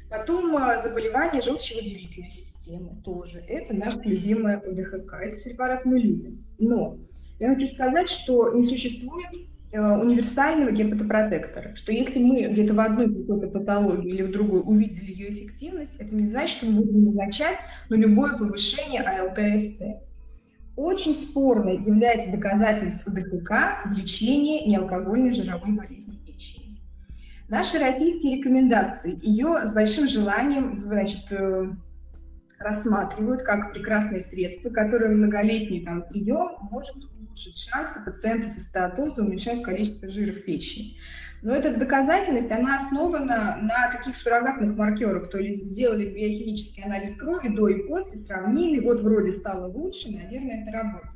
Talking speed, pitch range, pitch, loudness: 130 wpm, 200-250 Hz, 215 Hz, -24 LUFS